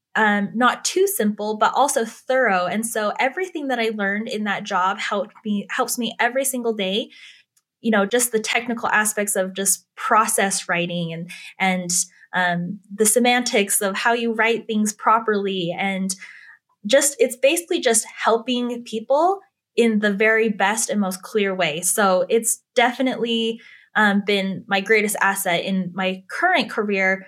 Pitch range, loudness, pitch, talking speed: 195-240 Hz, -20 LUFS, 220 Hz, 155 wpm